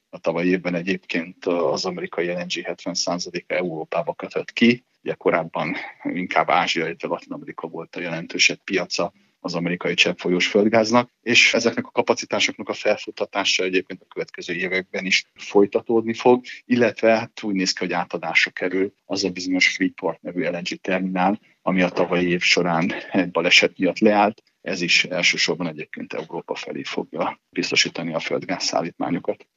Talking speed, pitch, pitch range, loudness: 155 wpm, 95 Hz, 90-115 Hz, -21 LUFS